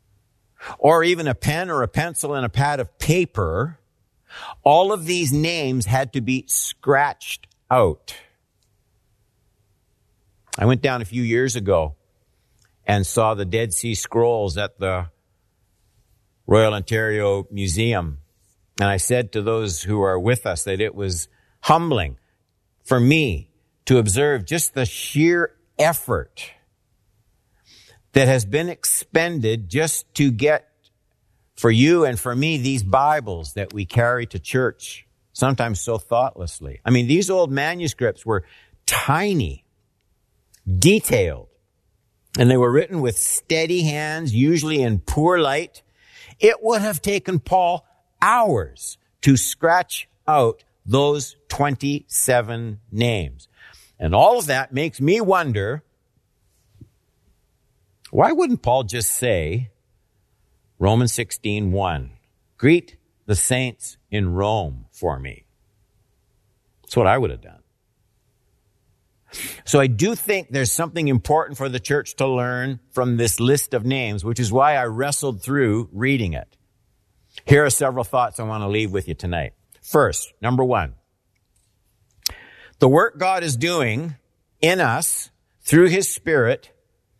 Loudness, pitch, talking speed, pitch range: -20 LUFS, 120 Hz, 130 wpm, 100-140 Hz